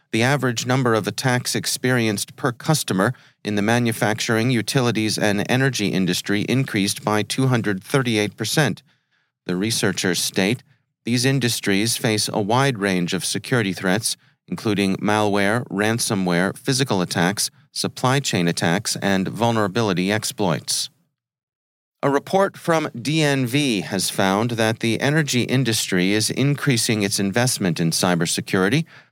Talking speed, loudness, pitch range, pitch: 115 wpm, -20 LUFS, 100-130 Hz, 115 Hz